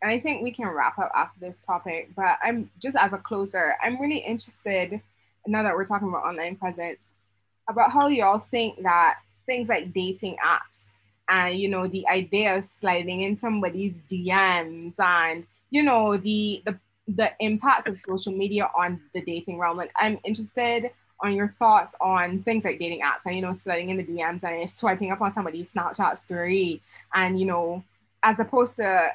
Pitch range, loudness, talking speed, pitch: 175-215 Hz, -25 LUFS, 185 wpm, 190 Hz